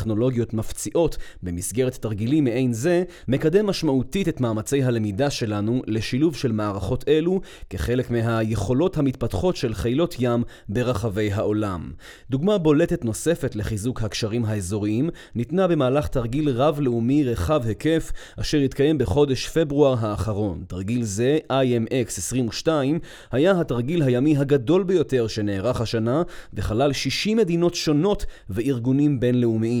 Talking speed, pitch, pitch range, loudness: 115 wpm, 125 Hz, 110-150 Hz, -23 LUFS